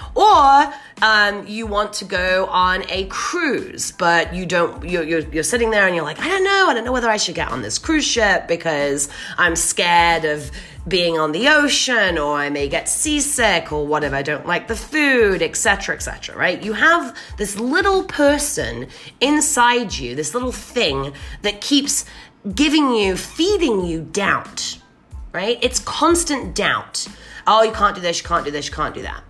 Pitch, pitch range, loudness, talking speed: 210 Hz, 170-285 Hz, -17 LUFS, 190 wpm